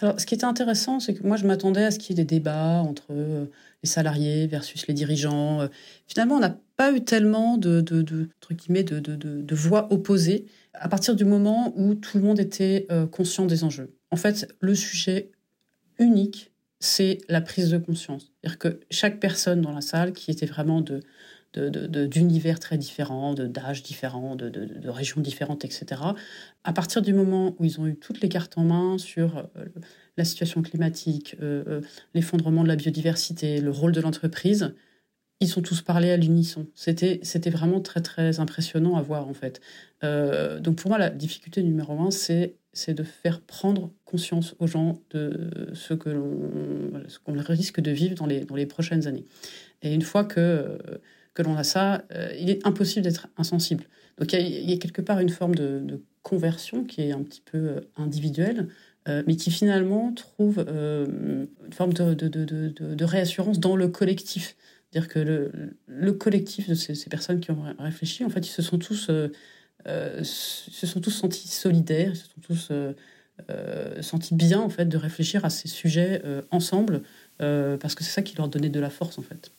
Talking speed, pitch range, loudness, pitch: 205 wpm, 155-190 Hz, -25 LUFS, 170 Hz